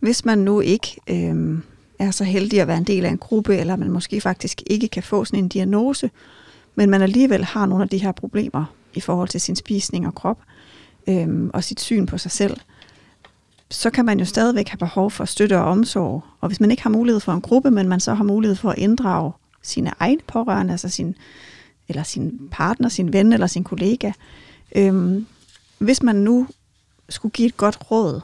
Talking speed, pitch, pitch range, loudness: 210 wpm, 200 Hz, 185-220 Hz, -20 LUFS